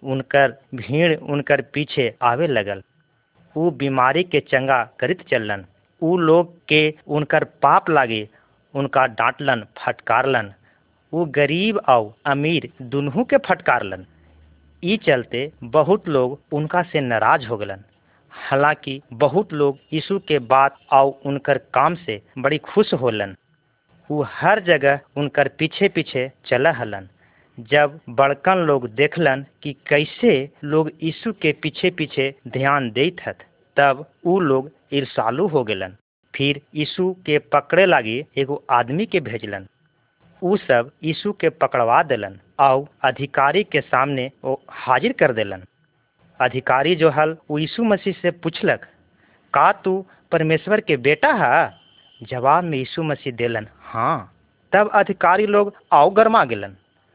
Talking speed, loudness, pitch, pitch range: 130 wpm, -19 LUFS, 145 Hz, 130-165 Hz